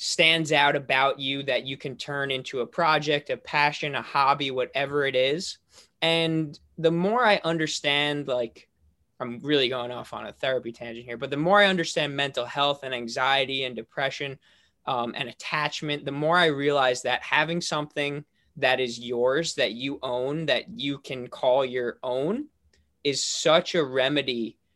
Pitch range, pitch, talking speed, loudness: 125-150 Hz, 140 Hz, 170 wpm, -25 LUFS